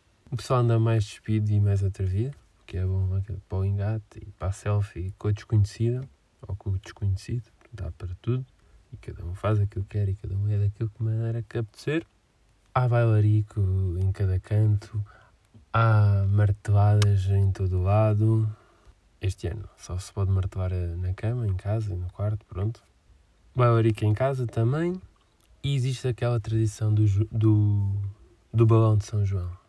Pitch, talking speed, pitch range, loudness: 105 Hz, 170 wpm, 95-115 Hz, -26 LUFS